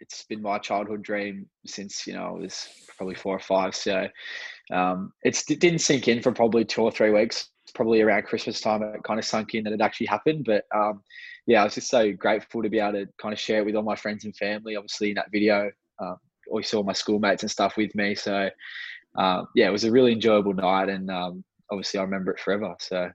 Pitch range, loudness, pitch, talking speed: 100-110 Hz, -25 LUFS, 105 Hz, 240 wpm